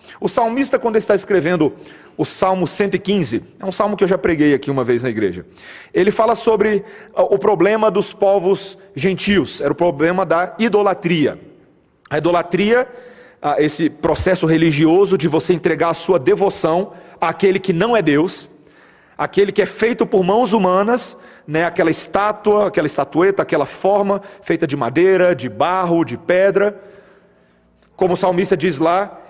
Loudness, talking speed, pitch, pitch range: -16 LUFS, 155 wpm, 190 Hz, 170-205 Hz